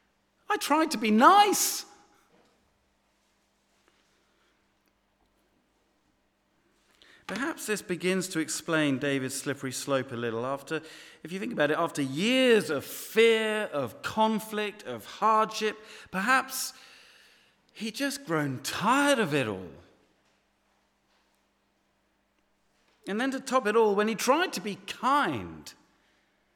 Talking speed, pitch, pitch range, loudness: 110 wpm, 215 Hz, 155-260 Hz, -27 LUFS